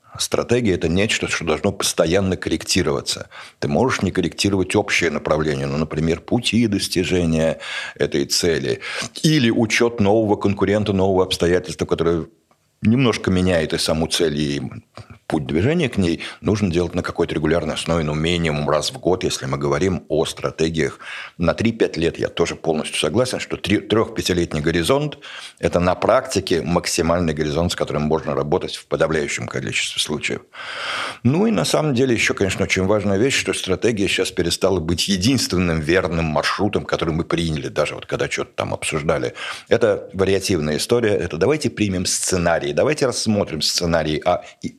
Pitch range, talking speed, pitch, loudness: 80-100 Hz, 155 wpm, 90 Hz, -20 LUFS